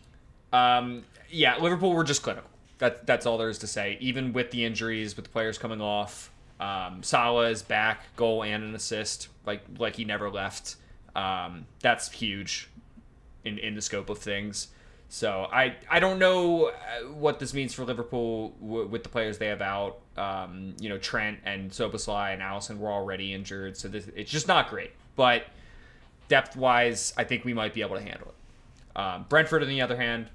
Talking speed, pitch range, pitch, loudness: 190 wpm, 105-125 Hz, 110 Hz, -28 LUFS